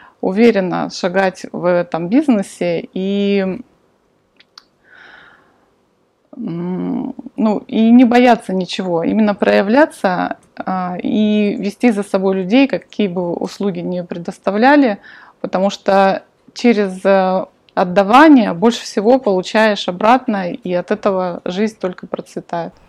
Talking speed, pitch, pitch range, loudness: 95 wpm, 200 Hz, 185-240 Hz, -15 LUFS